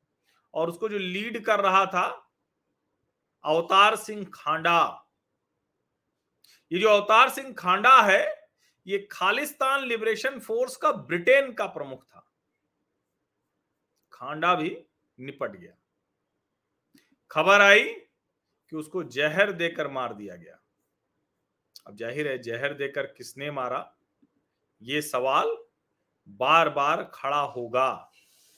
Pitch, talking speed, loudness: 200 Hz, 105 wpm, -24 LUFS